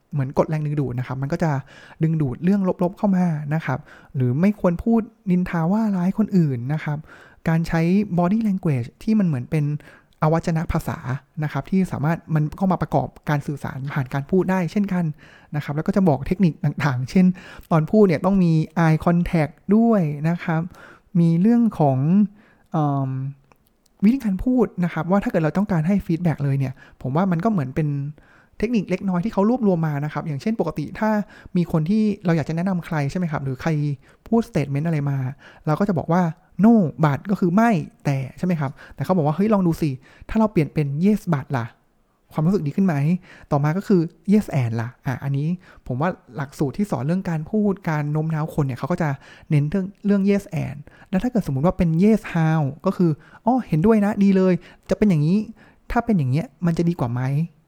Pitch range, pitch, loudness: 150-195 Hz, 170 Hz, -21 LUFS